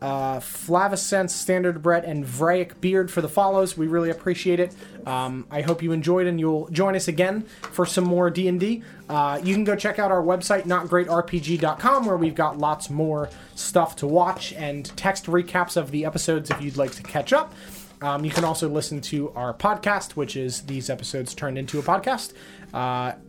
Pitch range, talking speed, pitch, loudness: 150-185 Hz, 190 wpm, 170 Hz, -24 LUFS